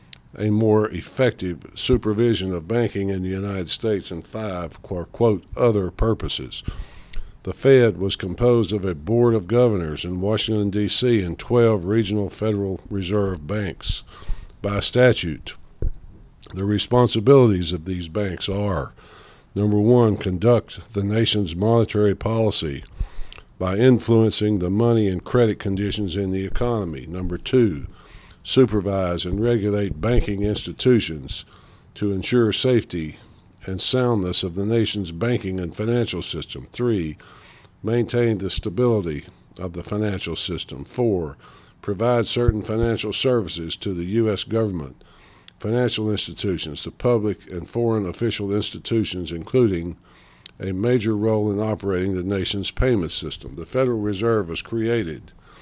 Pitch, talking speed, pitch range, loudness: 105 Hz, 125 wpm, 95-115 Hz, -21 LUFS